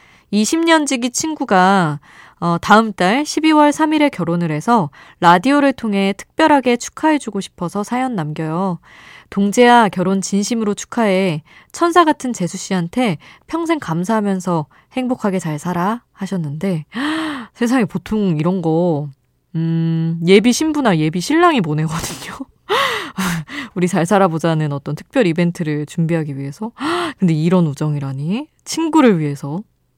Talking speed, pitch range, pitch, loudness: 280 characters per minute, 165-255 Hz, 195 Hz, -17 LUFS